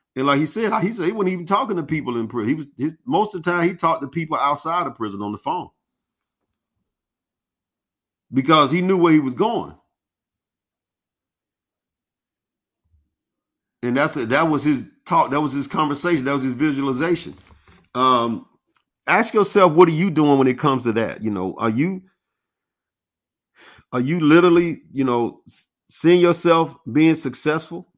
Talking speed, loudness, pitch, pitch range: 165 wpm, -19 LUFS, 150 Hz, 120-170 Hz